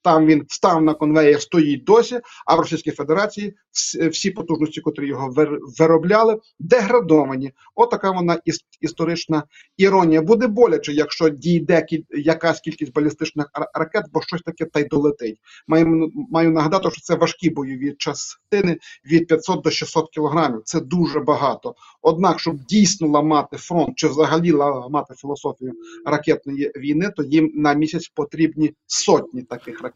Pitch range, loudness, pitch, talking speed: 150-170 Hz, -19 LUFS, 160 Hz, 140 wpm